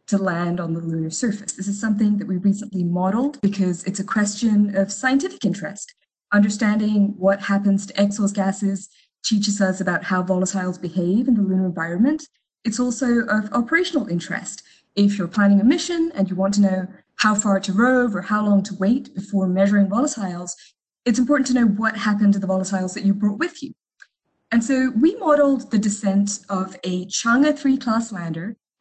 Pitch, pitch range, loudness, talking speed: 205 Hz, 190-235 Hz, -20 LUFS, 185 wpm